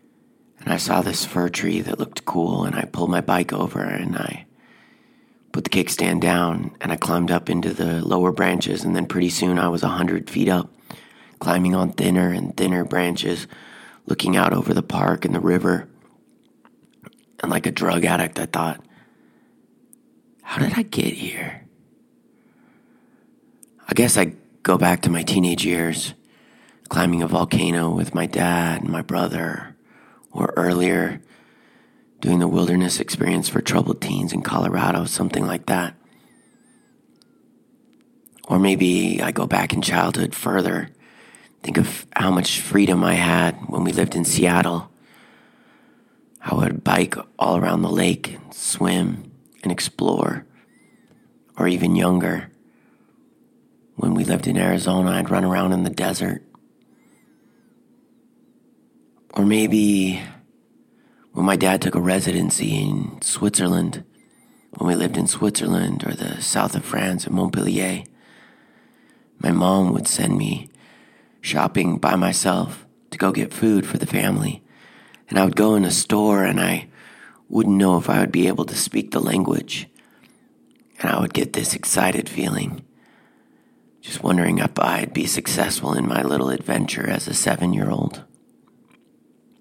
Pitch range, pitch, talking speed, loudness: 85-100 Hz, 90 Hz, 145 wpm, -21 LUFS